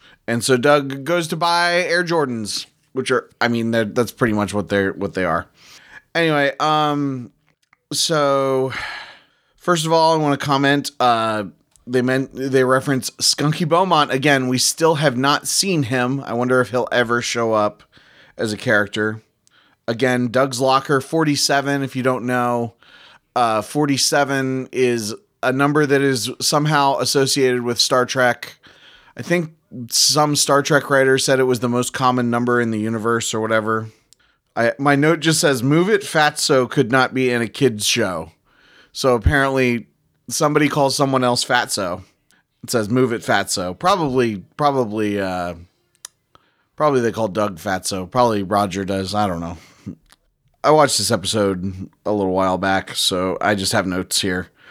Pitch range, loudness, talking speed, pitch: 110-140 Hz, -18 LUFS, 160 wpm, 125 Hz